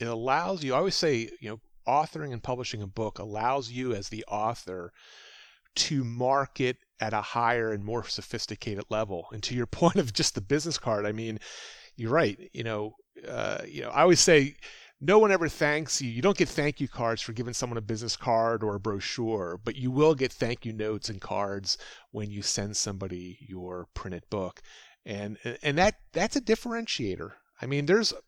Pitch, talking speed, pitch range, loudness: 115 Hz, 195 wpm, 105-140 Hz, -28 LUFS